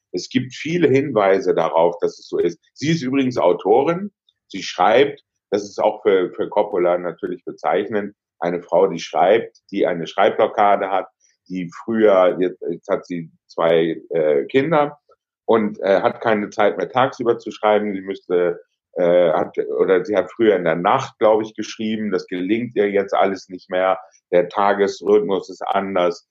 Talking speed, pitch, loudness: 165 wpm, 110 Hz, -19 LUFS